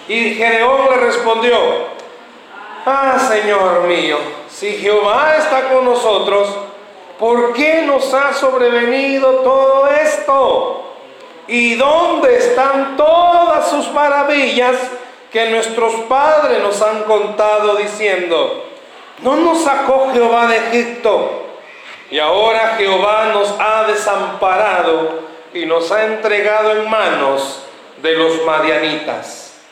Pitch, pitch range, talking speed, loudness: 235 Hz, 205-275 Hz, 105 wpm, -13 LUFS